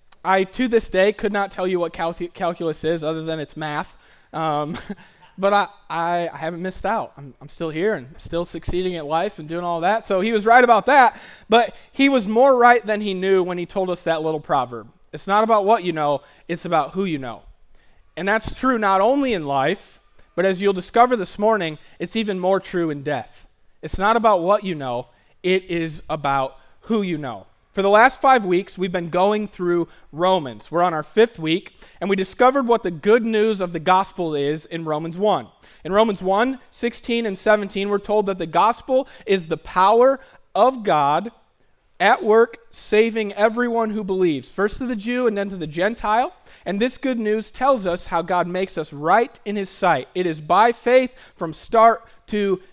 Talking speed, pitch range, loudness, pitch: 205 wpm, 165-220 Hz, -20 LUFS, 190 Hz